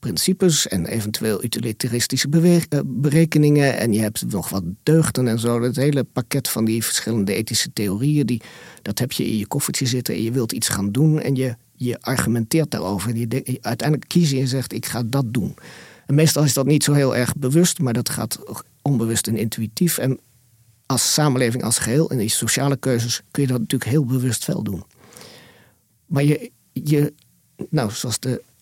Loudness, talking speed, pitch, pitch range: -20 LUFS, 190 wpm, 125 Hz, 115-145 Hz